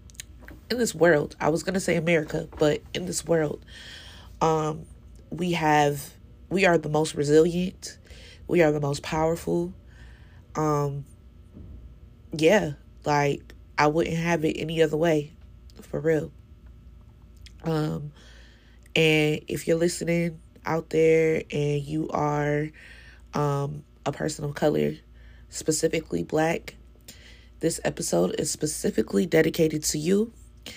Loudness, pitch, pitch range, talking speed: -25 LUFS, 155 Hz, 115-160 Hz, 120 wpm